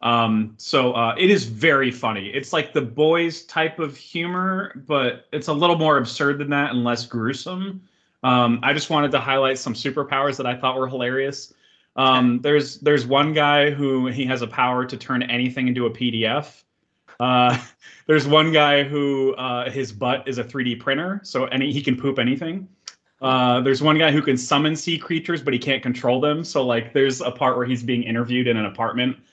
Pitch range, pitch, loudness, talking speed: 125-150 Hz, 135 Hz, -21 LUFS, 200 wpm